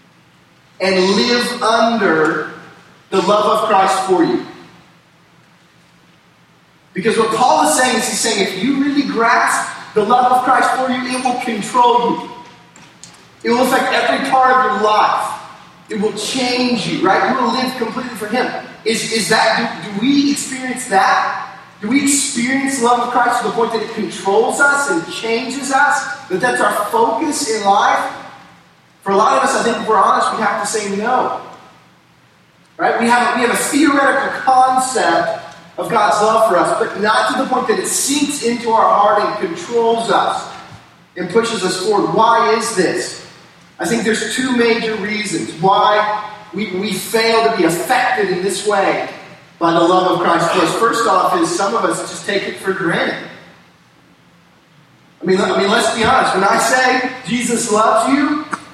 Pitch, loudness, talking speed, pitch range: 225 Hz, -15 LUFS, 180 wpm, 195-250 Hz